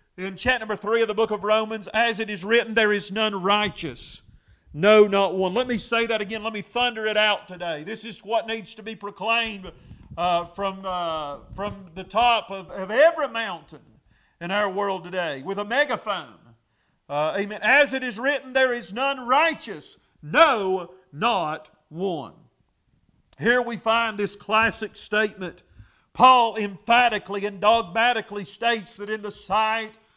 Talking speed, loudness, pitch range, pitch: 165 wpm, -23 LUFS, 190-230 Hz, 210 Hz